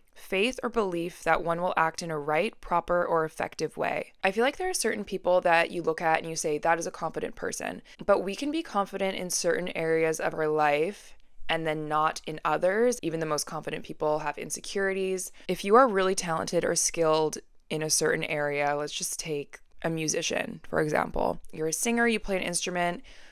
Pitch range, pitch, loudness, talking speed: 155-190 Hz, 170 Hz, -28 LUFS, 210 wpm